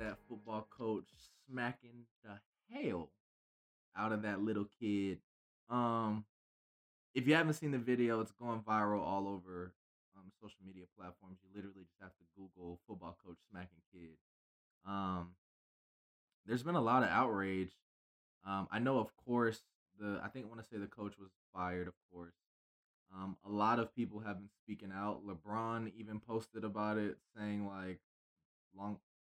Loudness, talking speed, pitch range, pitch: -40 LUFS, 160 wpm, 90-110 Hz, 100 Hz